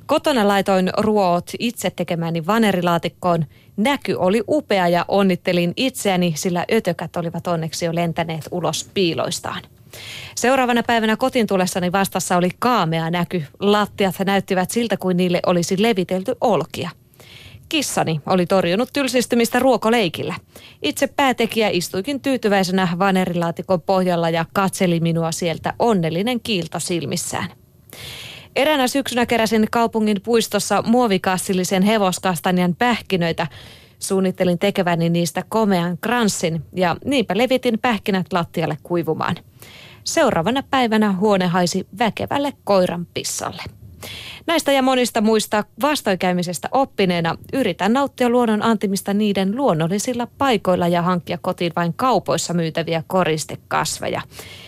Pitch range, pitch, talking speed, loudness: 175-230 Hz, 190 Hz, 110 wpm, -19 LUFS